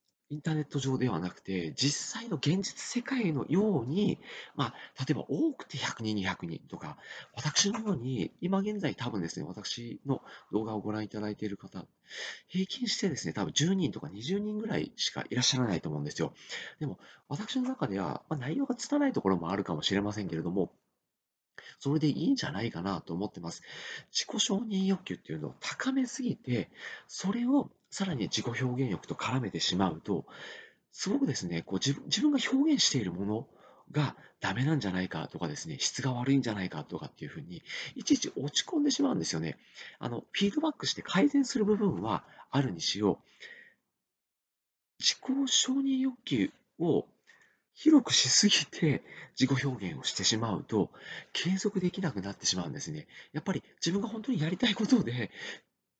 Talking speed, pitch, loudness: 360 characters per minute, 180 Hz, -31 LUFS